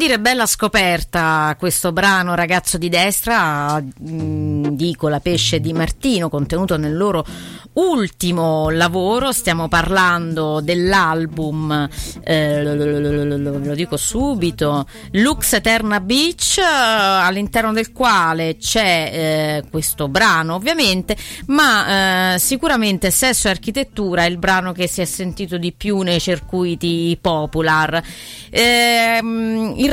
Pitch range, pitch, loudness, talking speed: 160-215 Hz, 180 Hz, -16 LUFS, 120 wpm